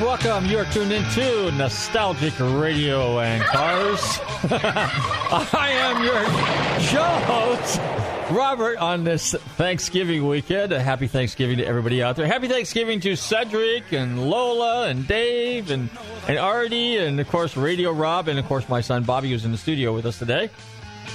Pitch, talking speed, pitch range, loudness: 155 Hz, 155 wpm, 125-210 Hz, -22 LUFS